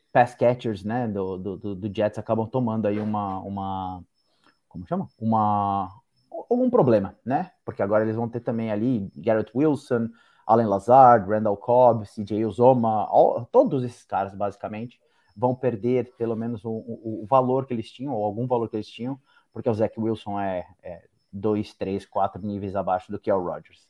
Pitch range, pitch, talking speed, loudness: 100-120 Hz, 110 Hz, 175 wpm, -24 LUFS